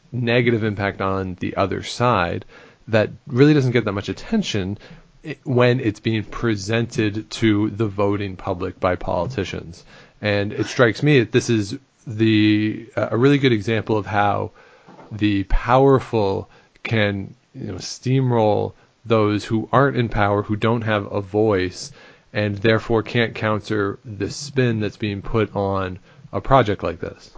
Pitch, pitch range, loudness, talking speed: 110 Hz, 100-120 Hz, -20 LUFS, 145 wpm